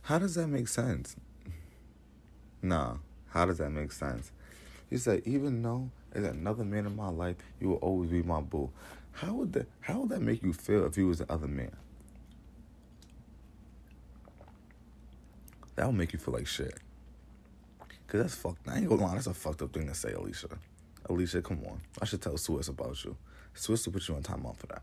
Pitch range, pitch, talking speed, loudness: 70-100 Hz, 85 Hz, 200 wpm, -34 LUFS